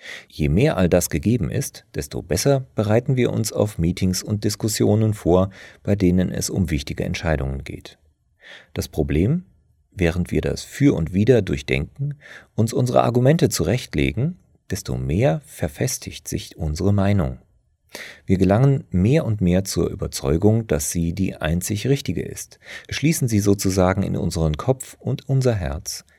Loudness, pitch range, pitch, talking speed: -21 LUFS, 85-120 Hz, 95 Hz, 145 wpm